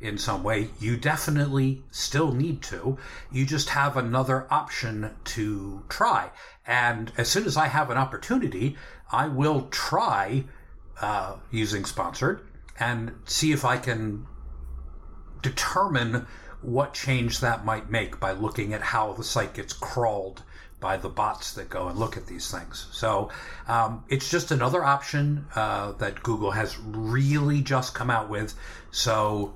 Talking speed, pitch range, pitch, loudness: 150 wpm, 105-135 Hz, 115 Hz, -27 LUFS